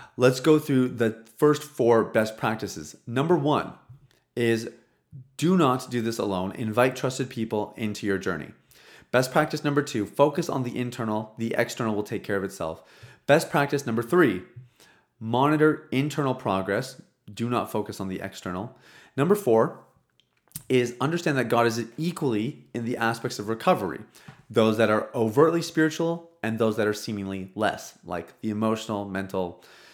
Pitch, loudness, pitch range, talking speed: 120 Hz, -26 LUFS, 110-140 Hz, 155 wpm